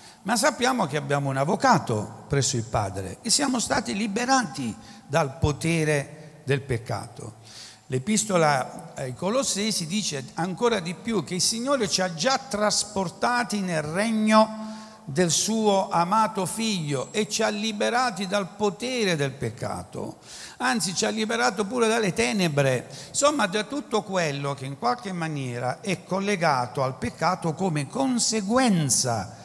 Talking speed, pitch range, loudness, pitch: 135 wpm, 145-220 Hz, -25 LUFS, 190 Hz